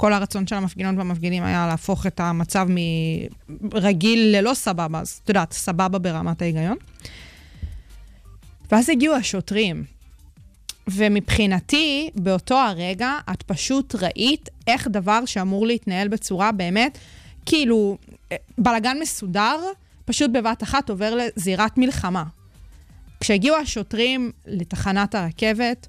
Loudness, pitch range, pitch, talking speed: -21 LUFS, 175-235 Hz, 200 Hz, 105 wpm